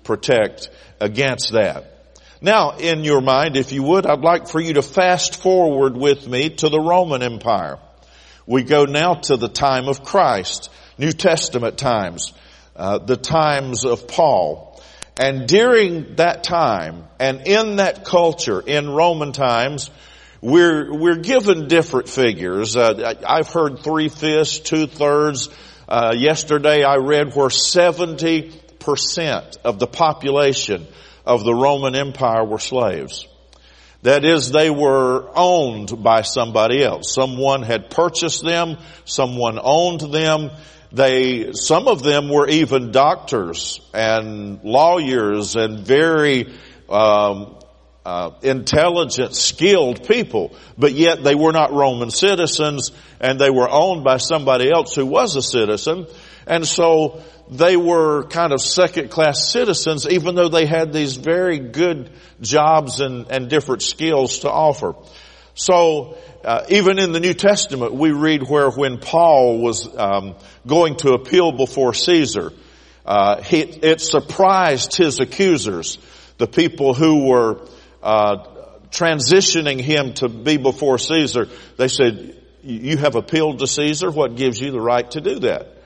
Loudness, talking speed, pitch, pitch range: -17 LUFS, 140 wpm, 145 Hz, 125-165 Hz